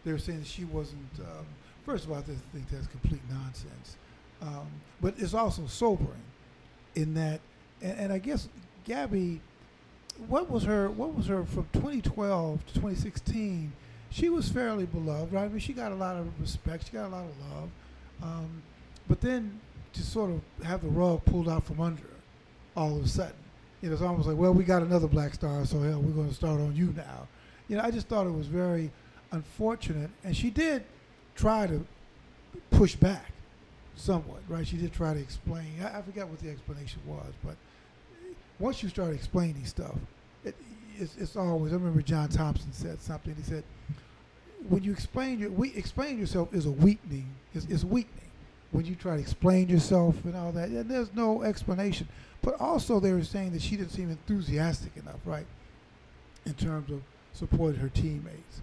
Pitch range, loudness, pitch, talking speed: 145-195 Hz, -31 LUFS, 165 Hz, 185 wpm